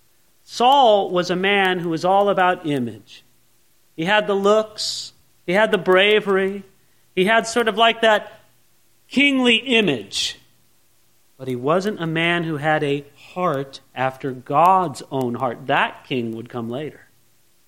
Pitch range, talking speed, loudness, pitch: 125-200 Hz, 145 wpm, -19 LUFS, 170 Hz